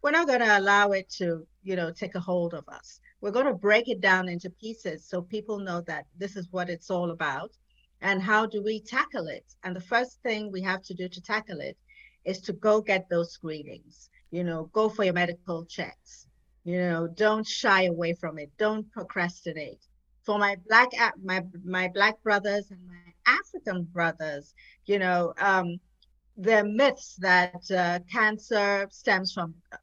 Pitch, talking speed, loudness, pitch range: 190 Hz, 185 wpm, -27 LUFS, 175-215 Hz